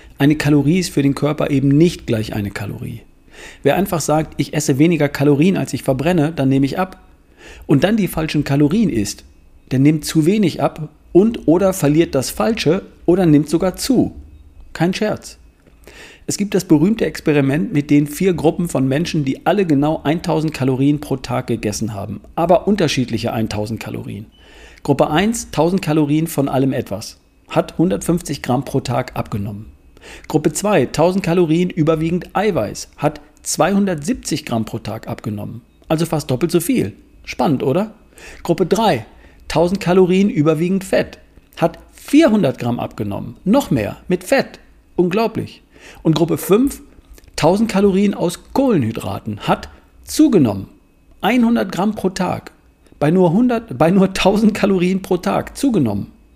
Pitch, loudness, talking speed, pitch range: 155 Hz, -17 LUFS, 150 wpm, 135-185 Hz